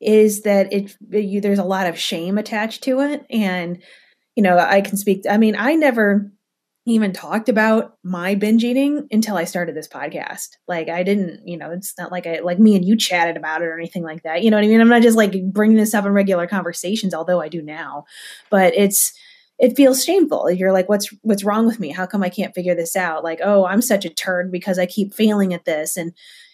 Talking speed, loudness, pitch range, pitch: 235 wpm, -18 LUFS, 180-215 Hz, 200 Hz